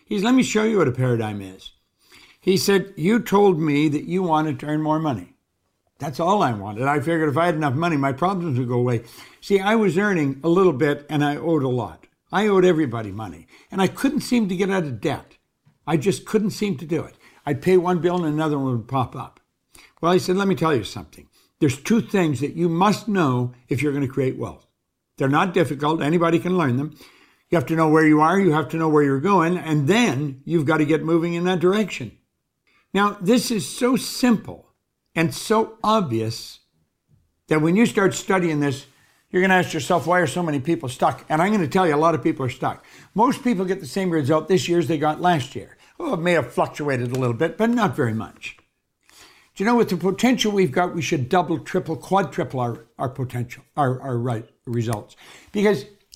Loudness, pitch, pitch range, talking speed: -21 LUFS, 165 Hz, 140-190 Hz, 230 wpm